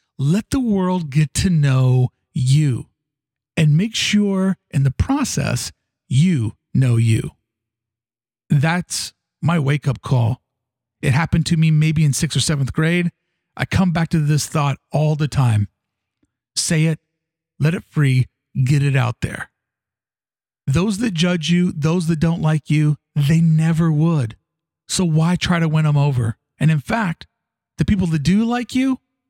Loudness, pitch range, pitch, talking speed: -18 LUFS, 130-170 Hz, 155 Hz, 160 wpm